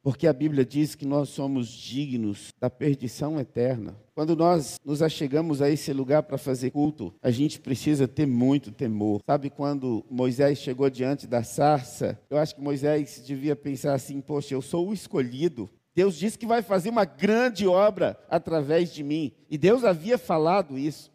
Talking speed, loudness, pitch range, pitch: 175 wpm, -26 LUFS, 130-155 Hz, 145 Hz